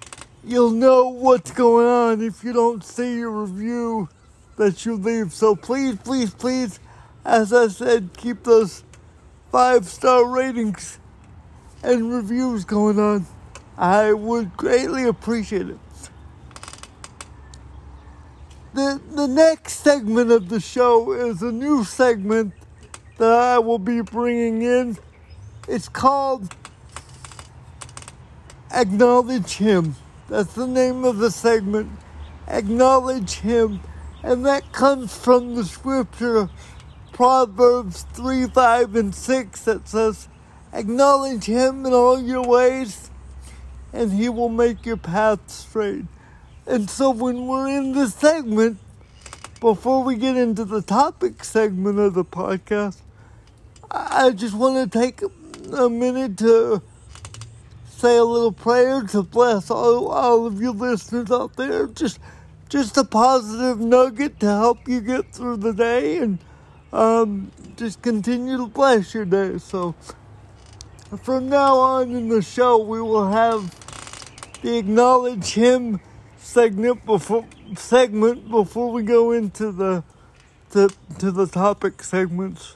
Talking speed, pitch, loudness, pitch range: 125 wpm, 230 Hz, -19 LUFS, 205-250 Hz